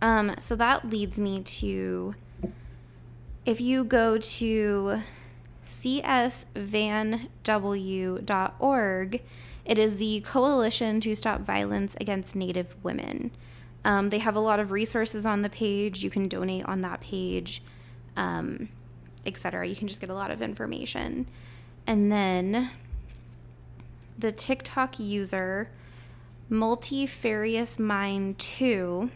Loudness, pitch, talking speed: -28 LUFS, 200 Hz, 110 wpm